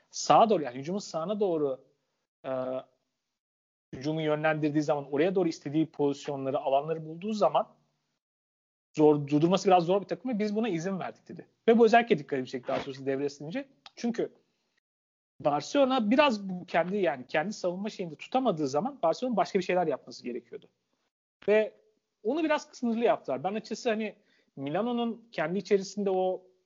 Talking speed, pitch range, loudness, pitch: 150 wpm, 145-215 Hz, -29 LUFS, 180 Hz